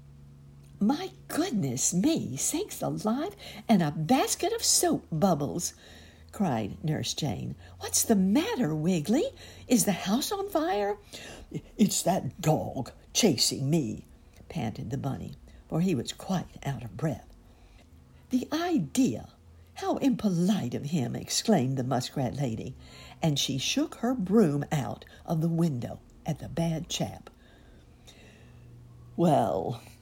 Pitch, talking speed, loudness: 155 Hz, 125 wpm, -28 LUFS